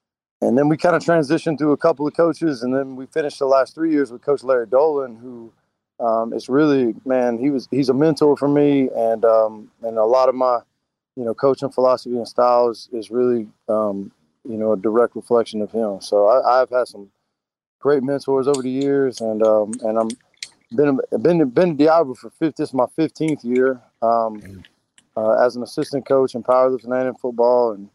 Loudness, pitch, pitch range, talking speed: -19 LUFS, 130 Hz, 115-145 Hz, 205 wpm